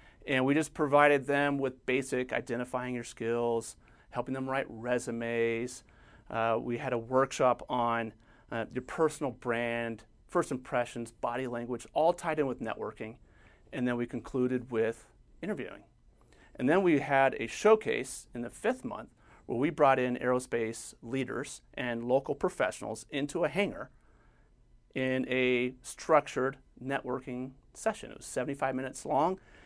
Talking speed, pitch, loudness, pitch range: 145 wpm, 125 Hz, -32 LUFS, 115-135 Hz